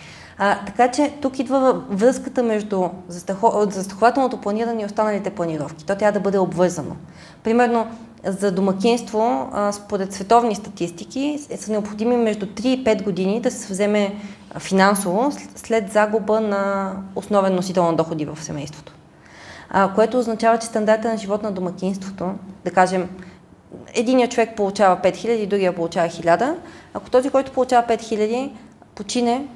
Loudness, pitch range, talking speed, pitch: -20 LUFS, 190-235 Hz, 140 wpm, 205 Hz